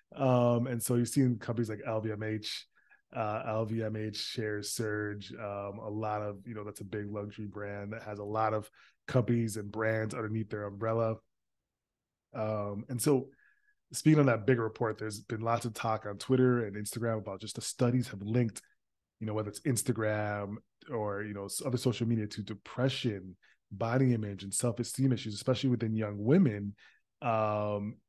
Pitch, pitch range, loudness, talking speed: 110 Hz, 105-120 Hz, -33 LUFS, 170 wpm